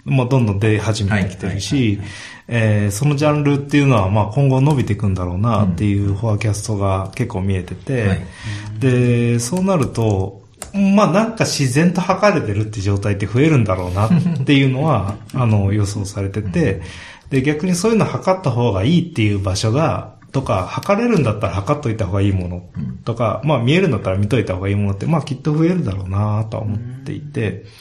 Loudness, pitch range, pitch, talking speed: -18 LUFS, 100-145 Hz, 110 Hz, 405 characters per minute